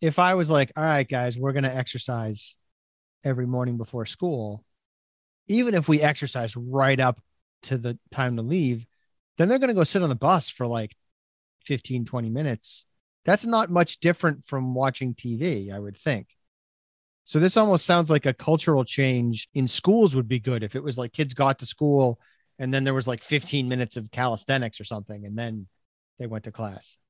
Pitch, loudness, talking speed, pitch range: 125 Hz, -24 LUFS, 195 wpm, 110-150 Hz